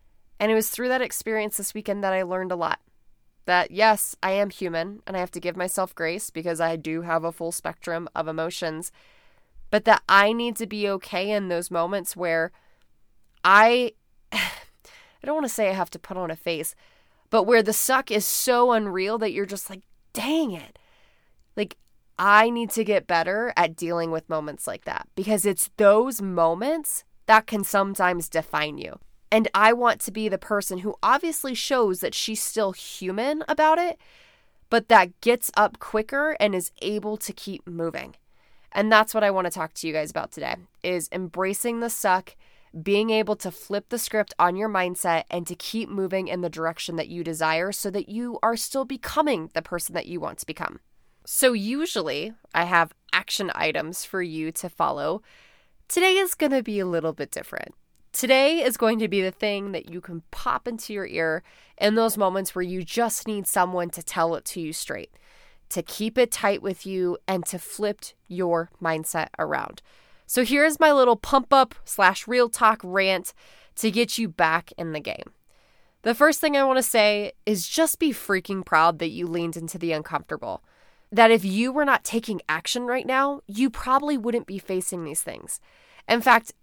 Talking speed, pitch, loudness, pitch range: 195 wpm, 200 Hz, -24 LUFS, 175-235 Hz